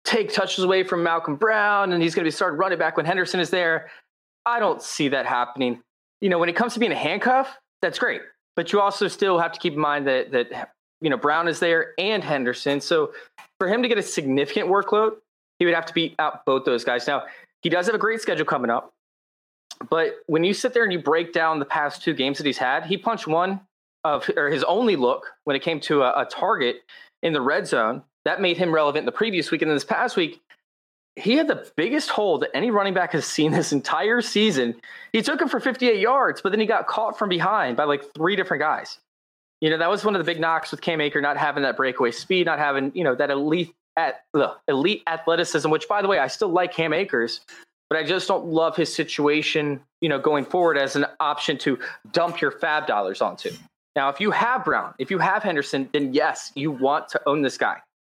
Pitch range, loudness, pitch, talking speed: 150-200 Hz, -22 LUFS, 170 Hz, 235 wpm